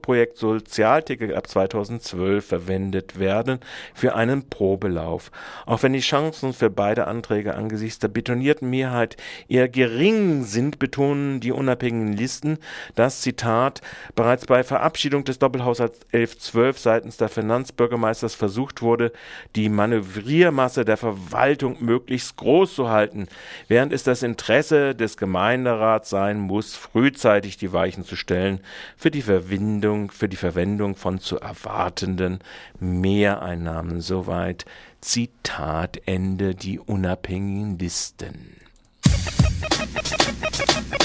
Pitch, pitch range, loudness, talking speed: 110 Hz, 95-125 Hz, -22 LUFS, 115 wpm